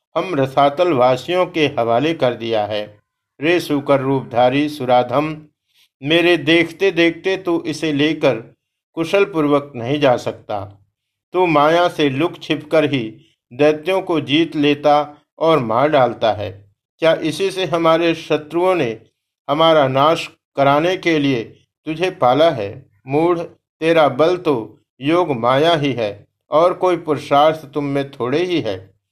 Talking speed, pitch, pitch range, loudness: 135 wpm, 150 Hz, 125-165 Hz, -17 LUFS